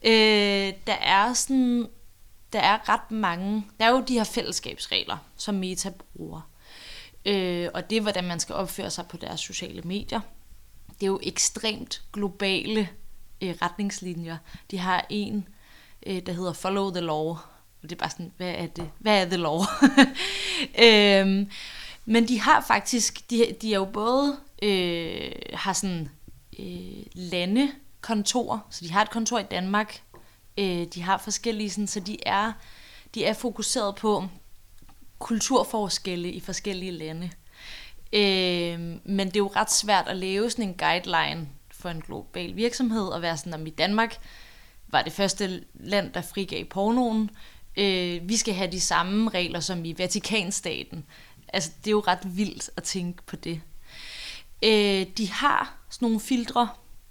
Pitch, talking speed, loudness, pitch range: 195 Hz, 160 wpm, -25 LUFS, 175-215 Hz